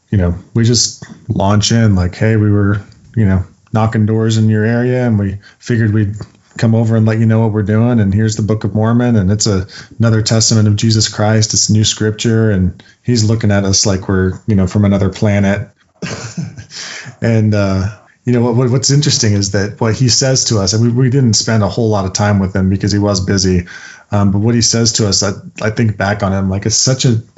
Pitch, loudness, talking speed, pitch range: 110 Hz, -13 LUFS, 235 wpm, 100-115 Hz